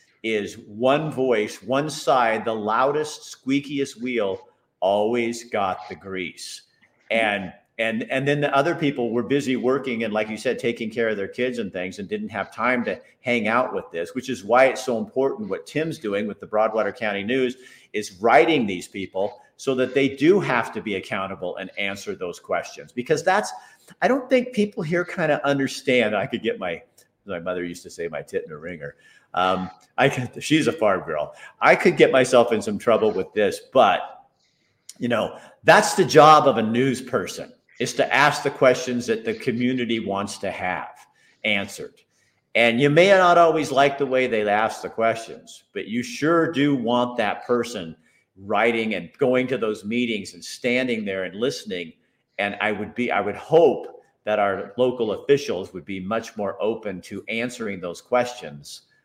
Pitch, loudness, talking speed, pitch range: 125 Hz, -22 LUFS, 190 wpm, 105-140 Hz